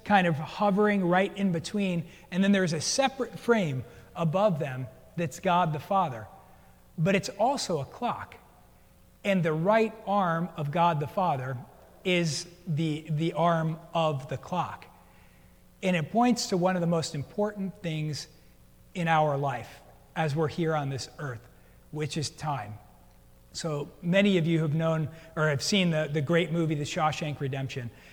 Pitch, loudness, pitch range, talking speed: 160 Hz, -28 LUFS, 145-180 Hz, 160 wpm